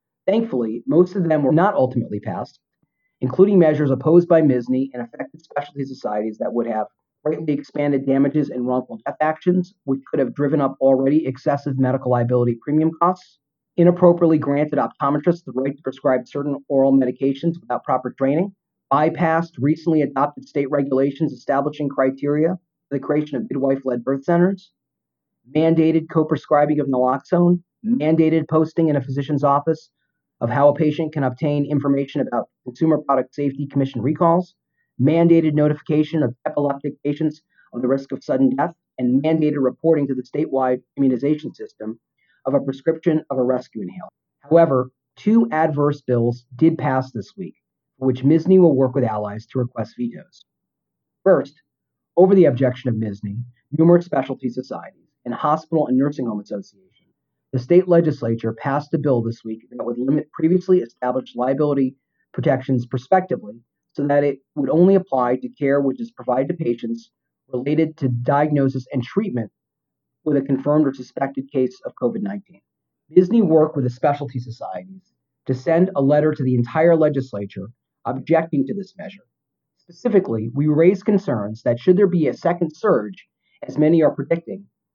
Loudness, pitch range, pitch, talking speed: -20 LUFS, 130-160 Hz, 140 Hz, 160 wpm